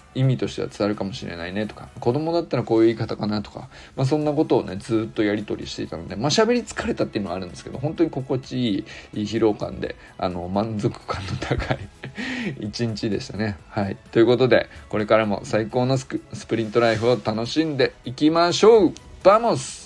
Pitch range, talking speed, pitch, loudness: 105-135 Hz, 425 characters per minute, 115 Hz, -23 LUFS